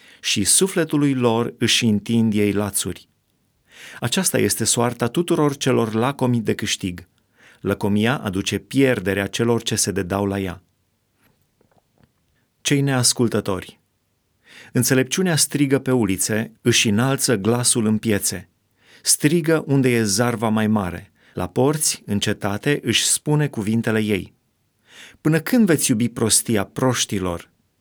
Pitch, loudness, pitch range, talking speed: 115 Hz, -19 LUFS, 100-130 Hz, 115 wpm